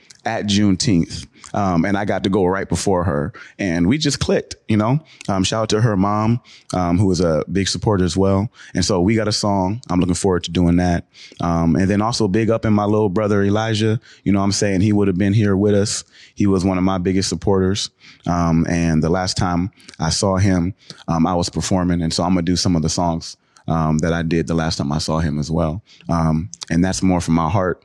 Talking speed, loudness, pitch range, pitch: 245 wpm, -18 LUFS, 85-105 Hz, 95 Hz